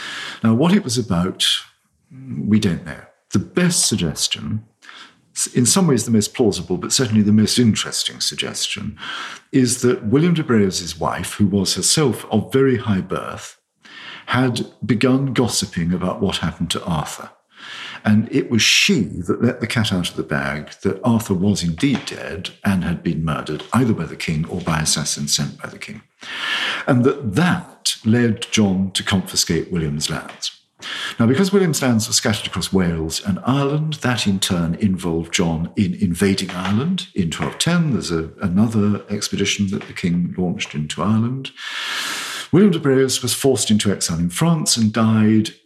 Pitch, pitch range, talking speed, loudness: 110 Hz, 90-130 Hz, 165 wpm, -19 LUFS